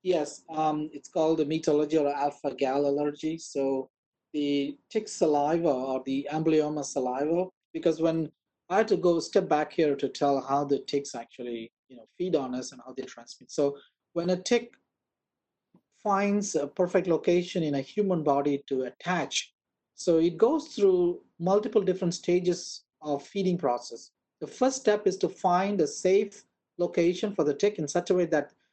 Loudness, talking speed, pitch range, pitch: -28 LUFS, 175 wpm, 140-180 Hz, 160 Hz